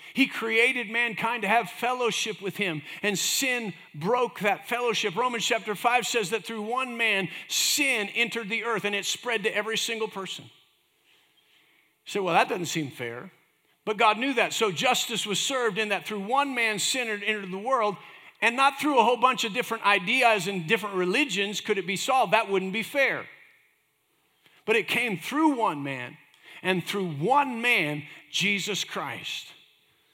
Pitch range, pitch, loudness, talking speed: 195-240 Hz, 220 Hz, -25 LUFS, 175 wpm